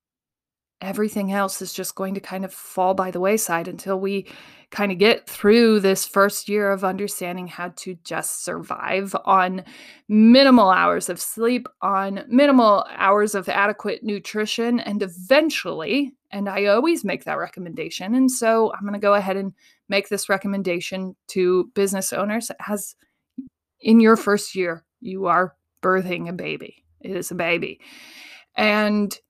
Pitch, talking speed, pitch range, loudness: 200 Hz, 155 wpm, 190-225 Hz, -20 LUFS